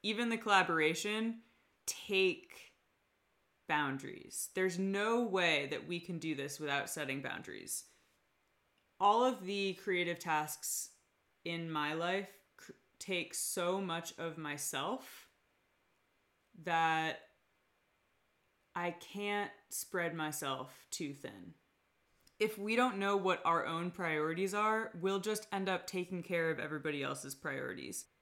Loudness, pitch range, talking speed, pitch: -36 LUFS, 155-200 Hz, 115 wpm, 175 Hz